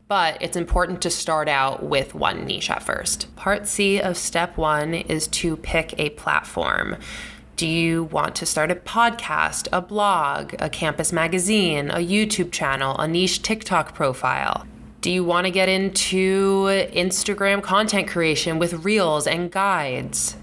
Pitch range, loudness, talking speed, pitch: 160-195 Hz, -21 LUFS, 155 wpm, 175 Hz